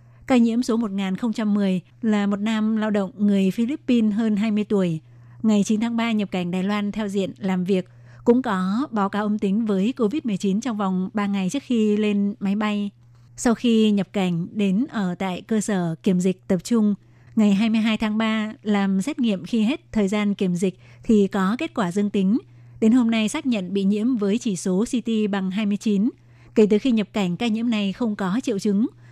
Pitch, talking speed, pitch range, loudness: 210 Hz, 205 wpm, 195-225 Hz, -22 LUFS